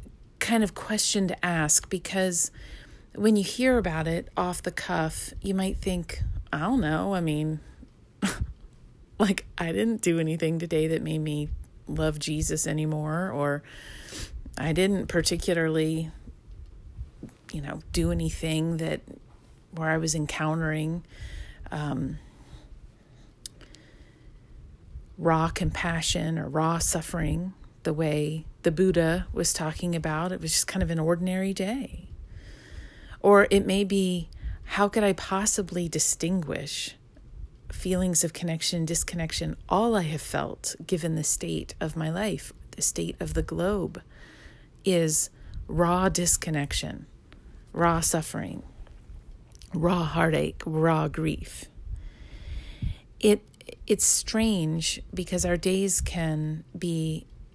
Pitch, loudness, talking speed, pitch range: 165 Hz, -27 LUFS, 120 wpm, 155-185 Hz